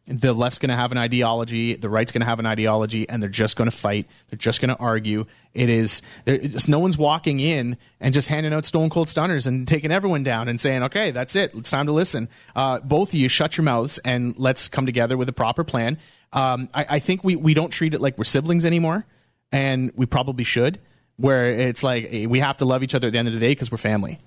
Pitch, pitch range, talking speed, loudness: 130 Hz, 115-150 Hz, 250 wpm, -21 LUFS